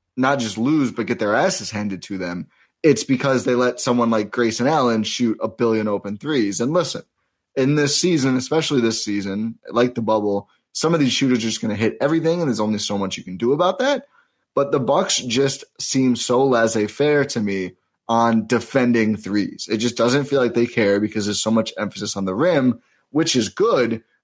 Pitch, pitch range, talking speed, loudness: 115 Hz, 105-130 Hz, 210 wpm, -20 LUFS